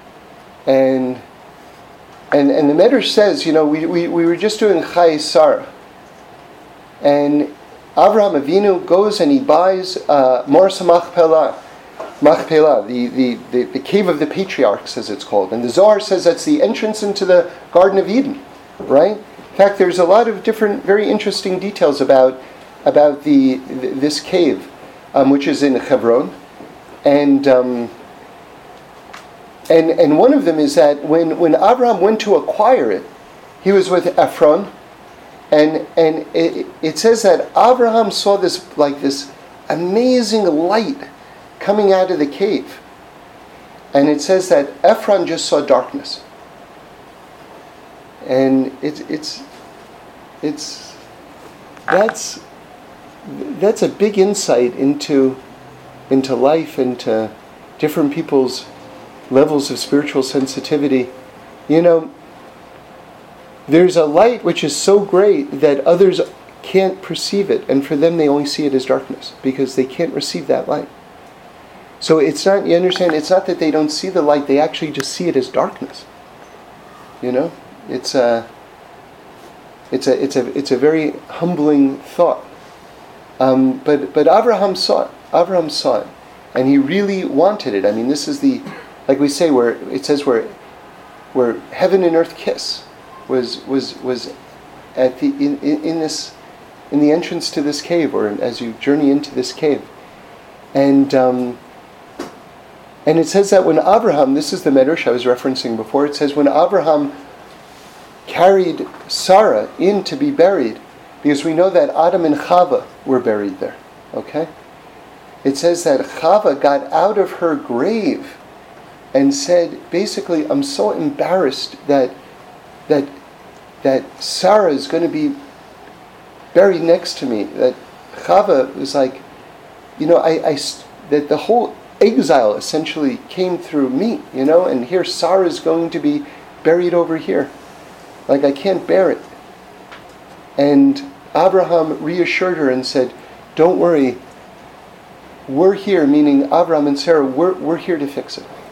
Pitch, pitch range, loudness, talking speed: 160 Hz, 140-190 Hz, -15 LUFS, 150 wpm